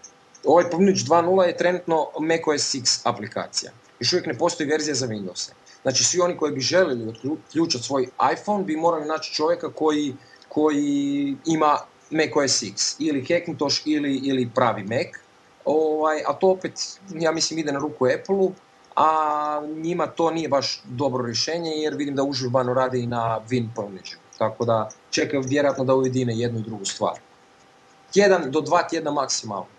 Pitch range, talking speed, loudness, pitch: 130-160 Hz, 165 wpm, -23 LUFS, 150 Hz